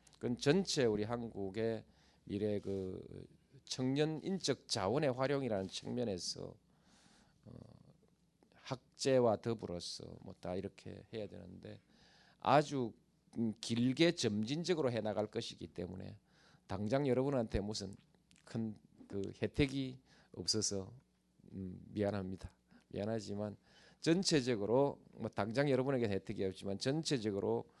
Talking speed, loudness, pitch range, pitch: 250 characters per minute, -38 LUFS, 100-135 Hz, 110 Hz